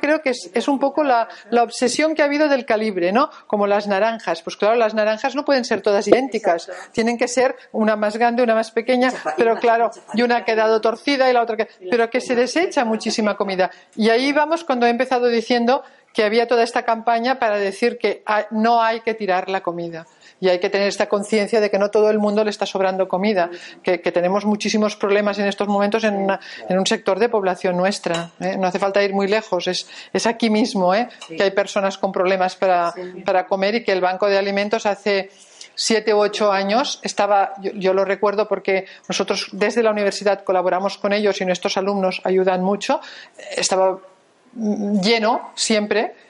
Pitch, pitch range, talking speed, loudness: 210 Hz, 195-230 Hz, 205 wpm, -19 LUFS